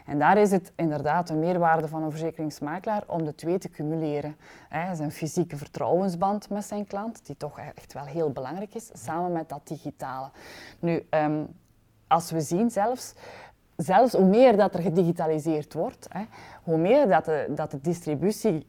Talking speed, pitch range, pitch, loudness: 175 wpm, 150-190 Hz, 165 Hz, -26 LUFS